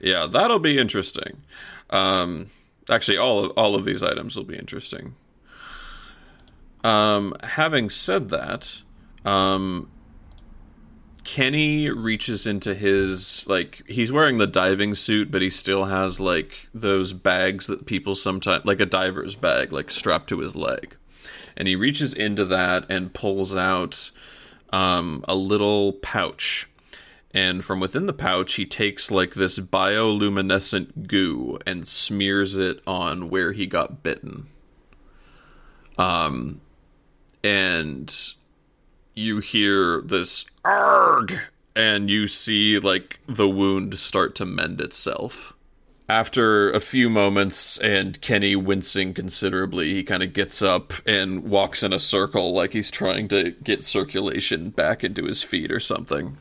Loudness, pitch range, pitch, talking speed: -21 LUFS, 95-105 Hz, 100 Hz, 135 wpm